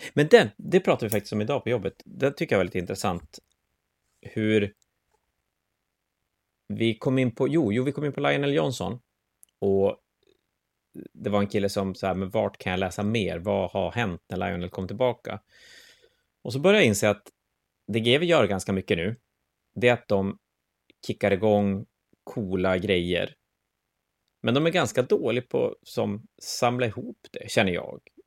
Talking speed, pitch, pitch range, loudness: 175 wpm, 105 Hz, 95-130 Hz, -25 LUFS